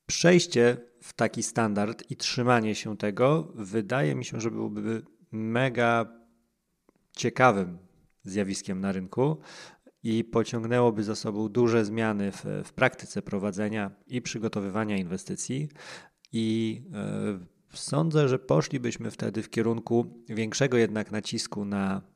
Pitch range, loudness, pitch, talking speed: 105-120 Hz, -28 LUFS, 115 Hz, 115 wpm